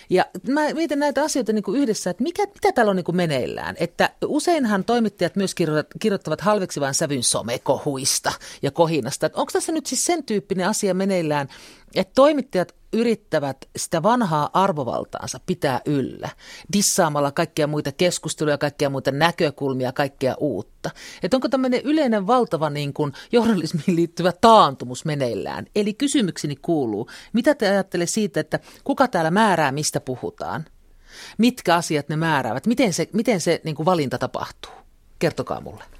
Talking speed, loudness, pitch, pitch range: 150 wpm, -21 LUFS, 180 Hz, 150-230 Hz